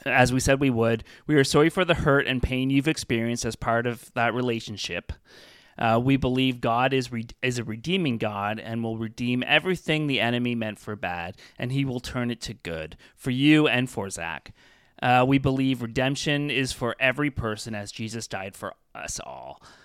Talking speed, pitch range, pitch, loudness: 195 wpm, 115-135 Hz, 125 Hz, -25 LUFS